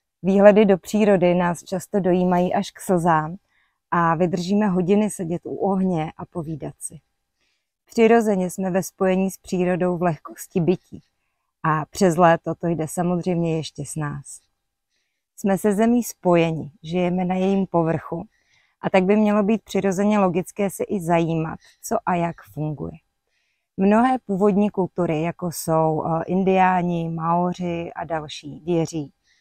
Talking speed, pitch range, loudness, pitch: 140 wpm, 165-195 Hz, -21 LUFS, 180 Hz